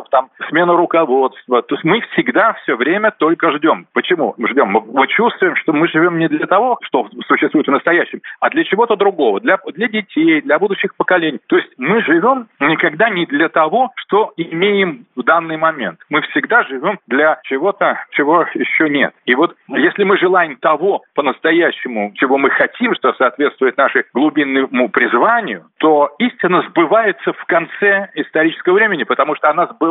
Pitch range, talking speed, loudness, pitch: 155-215 Hz, 165 wpm, -14 LUFS, 175 Hz